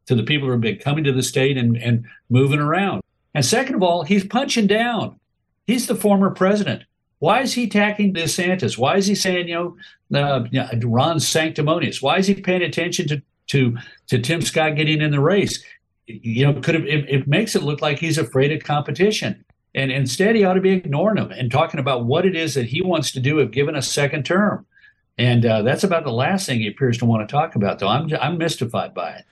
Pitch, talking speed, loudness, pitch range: 155 Hz, 230 wpm, -19 LUFS, 130-185 Hz